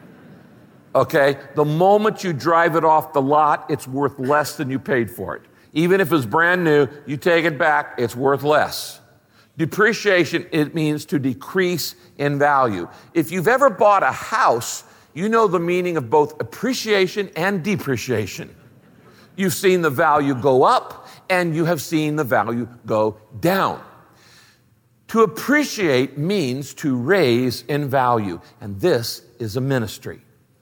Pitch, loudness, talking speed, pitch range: 150 Hz, -19 LUFS, 150 wpm, 130-175 Hz